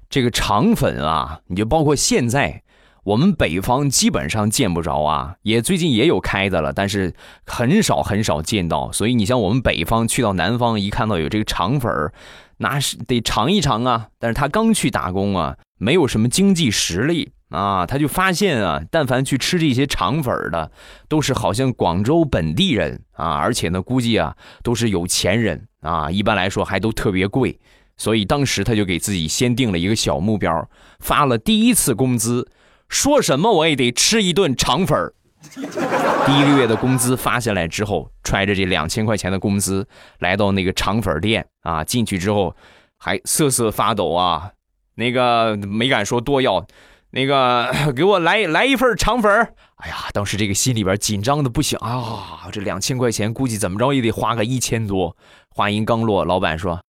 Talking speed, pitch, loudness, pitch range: 275 characters per minute, 115 Hz, -18 LUFS, 100-130 Hz